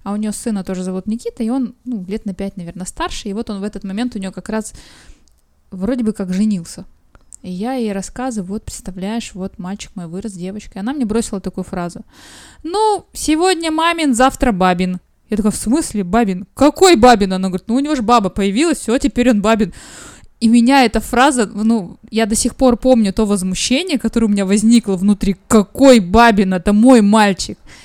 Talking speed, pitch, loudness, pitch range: 200 wpm, 220 Hz, -15 LUFS, 195-250 Hz